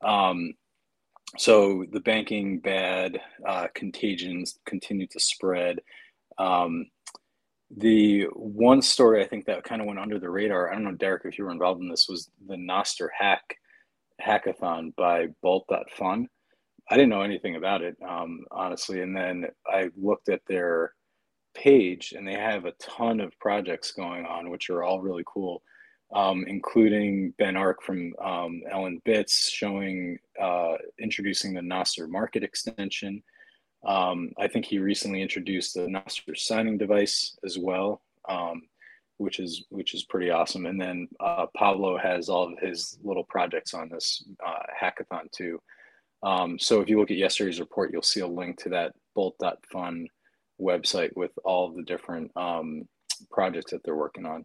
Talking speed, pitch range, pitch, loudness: 160 wpm, 90-100 Hz, 95 Hz, -27 LUFS